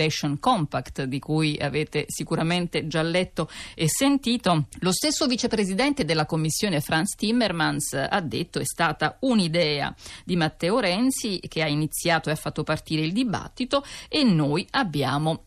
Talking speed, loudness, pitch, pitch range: 140 wpm, -24 LUFS, 165 Hz, 155-220 Hz